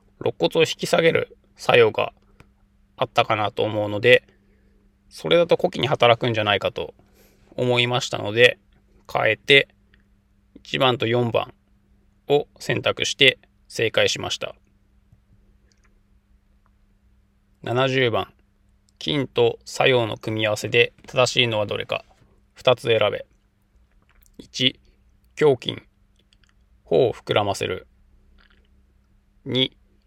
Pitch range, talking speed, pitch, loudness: 100-125 Hz, 185 characters per minute, 105 Hz, -21 LUFS